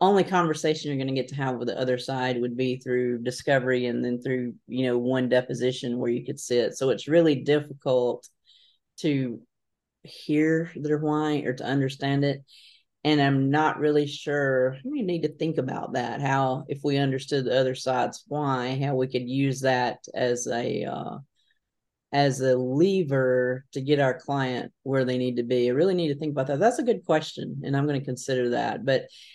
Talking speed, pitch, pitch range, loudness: 195 wpm, 135 Hz, 125-150 Hz, -26 LUFS